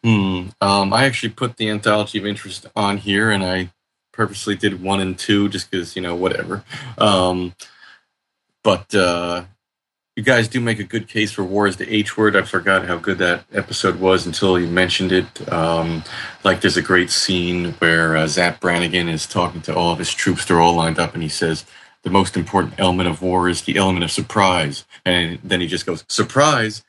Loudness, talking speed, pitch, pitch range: -18 LUFS, 205 wpm, 95 Hz, 90-105 Hz